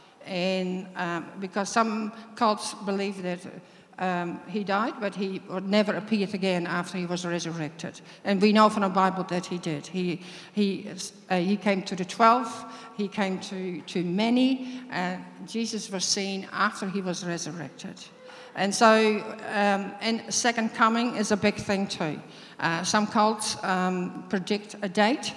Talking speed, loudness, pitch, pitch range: 160 wpm, -27 LUFS, 195 Hz, 180-215 Hz